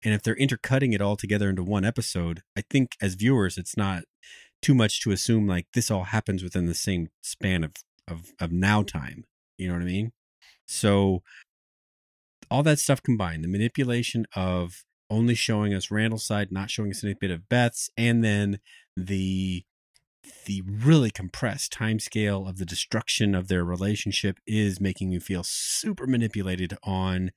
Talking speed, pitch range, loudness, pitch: 175 wpm, 95-110 Hz, -26 LUFS, 100 Hz